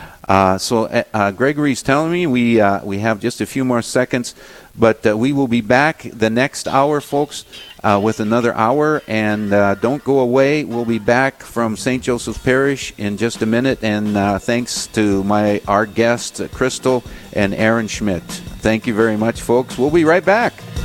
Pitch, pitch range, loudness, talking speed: 115 Hz, 105-130 Hz, -17 LUFS, 185 wpm